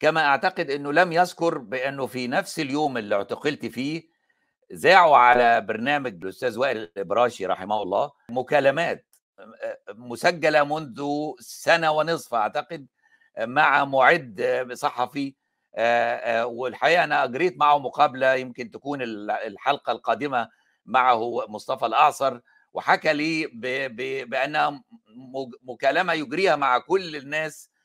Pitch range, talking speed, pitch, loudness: 130-165 Hz, 105 wpm, 145 Hz, -23 LUFS